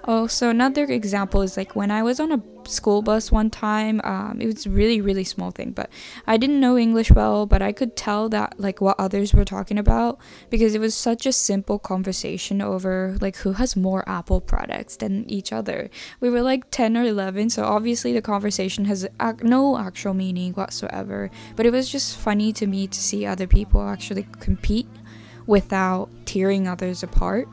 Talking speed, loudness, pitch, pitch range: 190 wpm, -22 LUFS, 205 Hz, 190-225 Hz